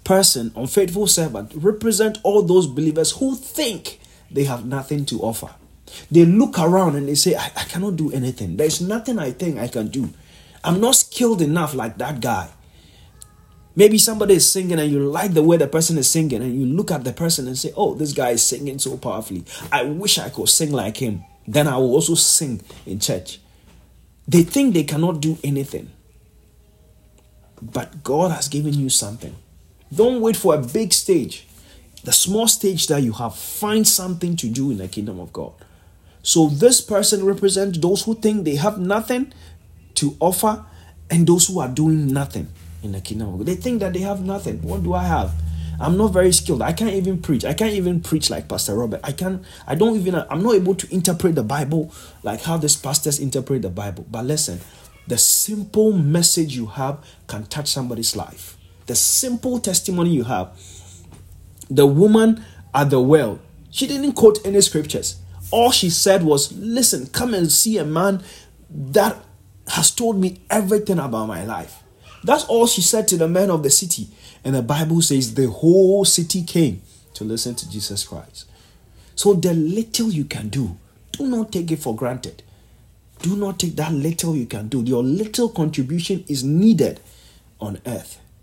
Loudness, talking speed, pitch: -18 LUFS, 185 wpm, 150 Hz